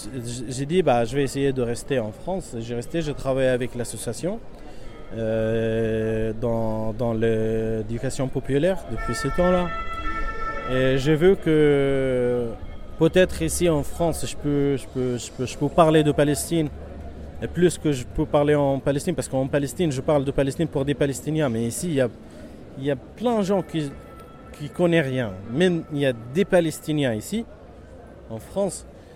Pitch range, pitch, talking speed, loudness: 120-160 Hz, 140 Hz, 170 wpm, -23 LUFS